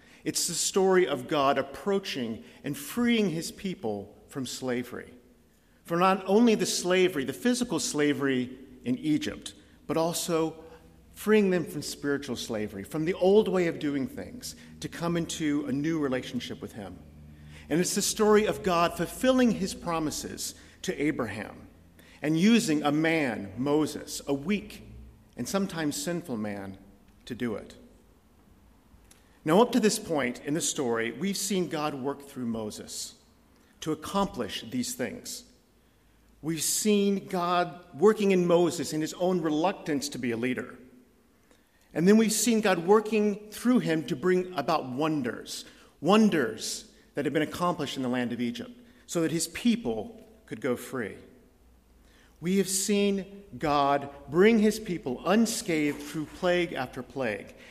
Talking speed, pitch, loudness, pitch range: 150 wpm, 165 Hz, -28 LUFS, 140-200 Hz